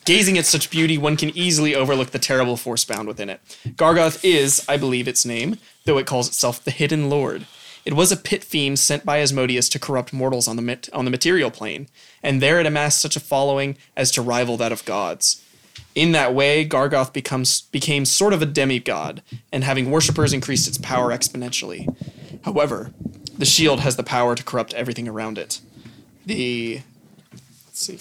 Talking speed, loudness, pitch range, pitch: 190 wpm, -19 LUFS, 125-150 Hz, 135 Hz